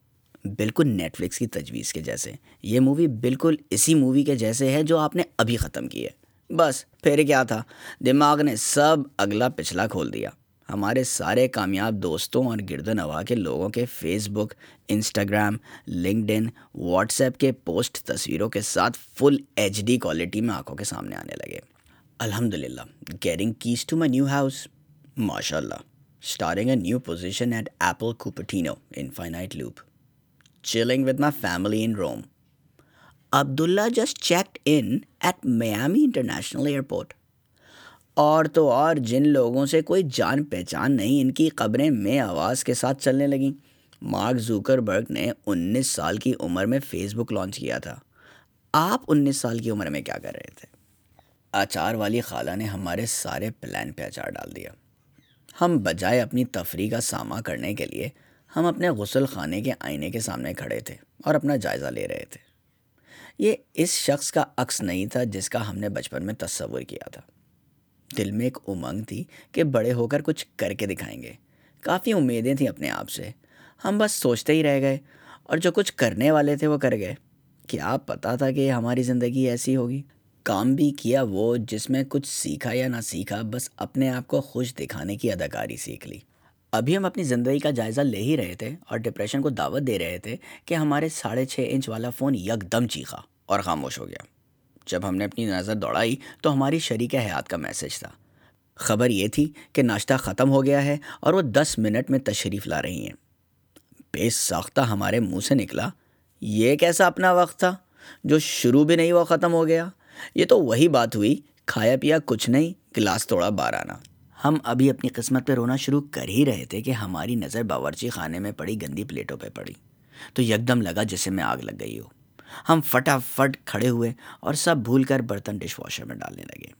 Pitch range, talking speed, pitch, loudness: 110-145 Hz, 185 wpm, 125 Hz, -24 LUFS